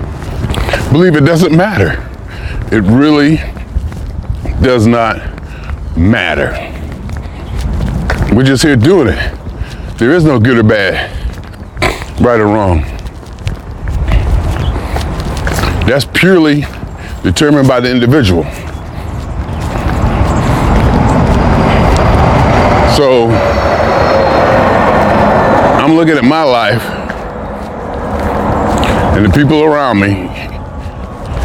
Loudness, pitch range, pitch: -10 LUFS, 80-125 Hz, 95 Hz